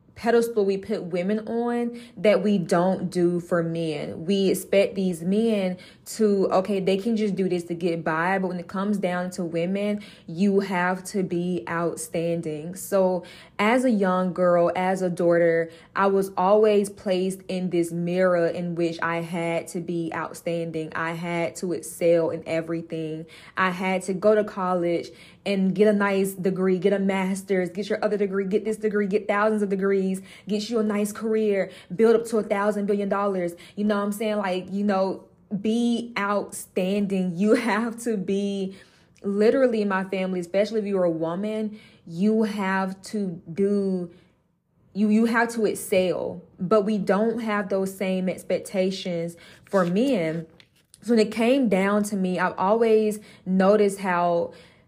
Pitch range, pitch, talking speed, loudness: 175-210 Hz, 190 Hz, 170 wpm, -24 LUFS